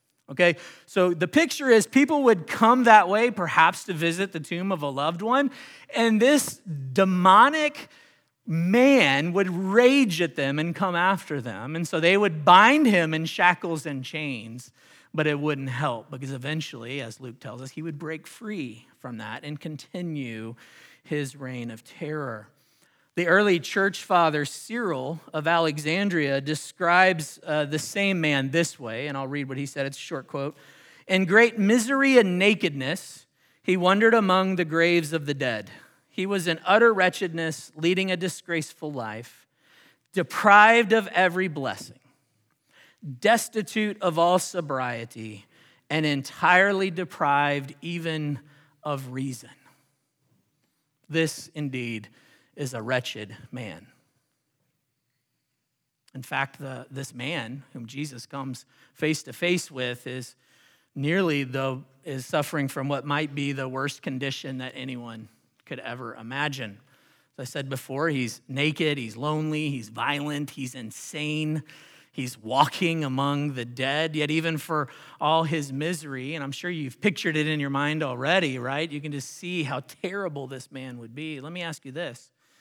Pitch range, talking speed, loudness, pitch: 135-180 Hz, 150 wpm, -24 LUFS, 150 Hz